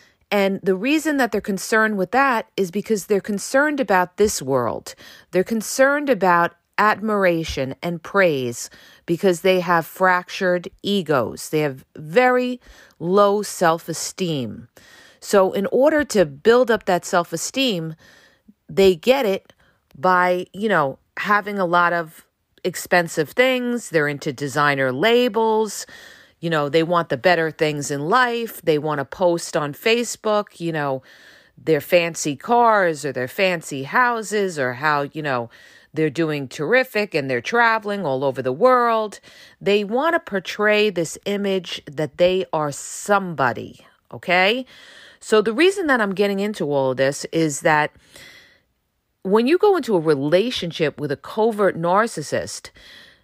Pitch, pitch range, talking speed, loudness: 185 Hz, 155-215 Hz, 145 wpm, -20 LUFS